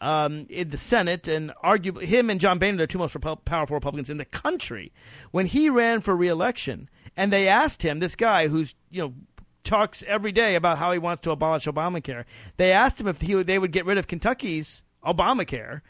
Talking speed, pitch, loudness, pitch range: 215 wpm, 175 Hz, -24 LUFS, 155-195 Hz